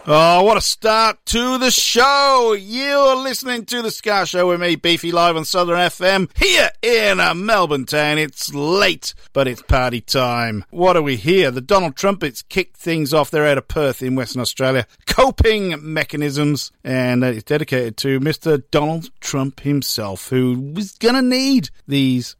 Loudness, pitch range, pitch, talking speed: -17 LUFS, 135-205 Hz, 160 Hz, 170 wpm